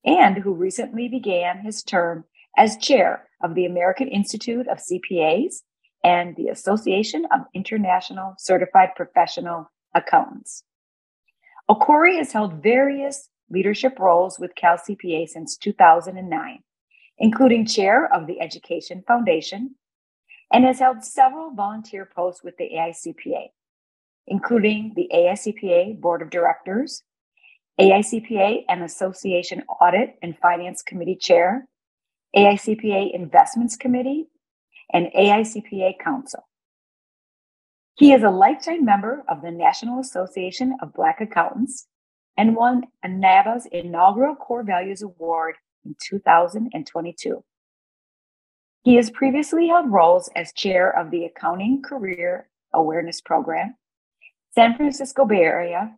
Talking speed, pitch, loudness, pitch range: 115 wpm, 200 Hz, -20 LUFS, 180-255 Hz